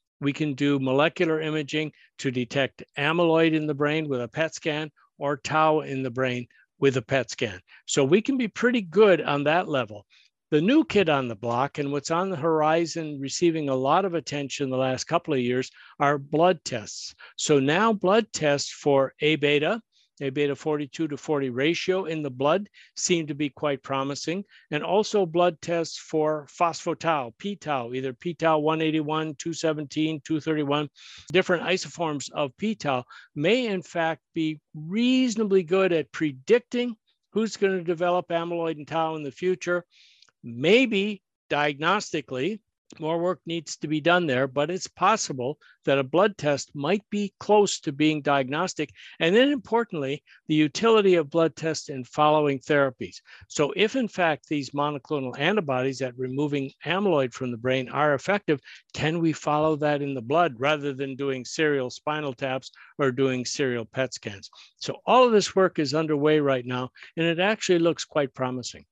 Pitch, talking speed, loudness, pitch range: 155 Hz, 170 wpm, -25 LUFS, 140-175 Hz